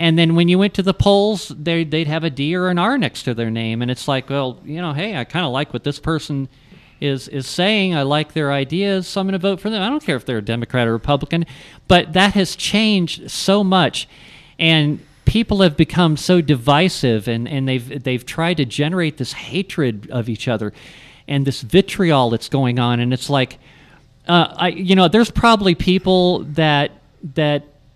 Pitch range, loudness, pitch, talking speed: 135-180 Hz, -17 LUFS, 155 Hz, 210 wpm